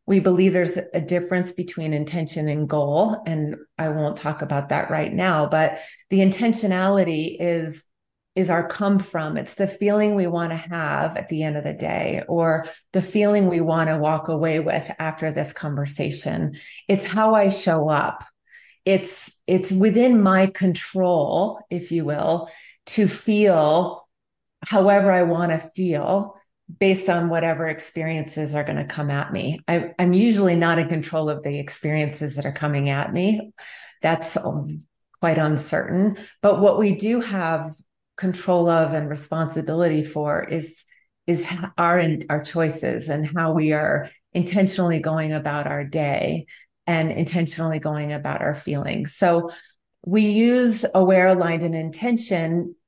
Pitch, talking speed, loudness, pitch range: 170 Hz, 150 wpm, -21 LUFS, 155-190 Hz